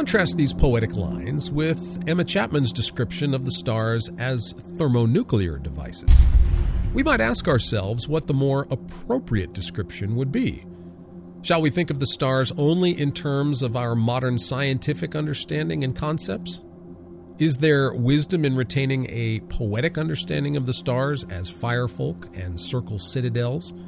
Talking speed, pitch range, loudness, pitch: 145 wpm, 95-150 Hz, -23 LUFS, 125 Hz